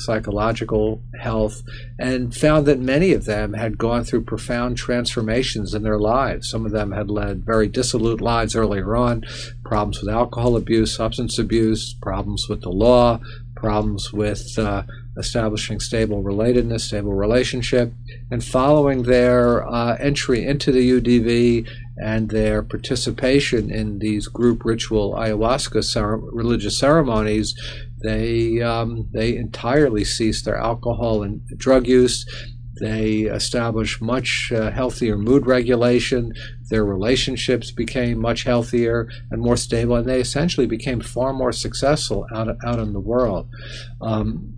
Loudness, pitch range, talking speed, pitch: -20 LUFS, 110-120 Hz, 135 wpm, 115 Hz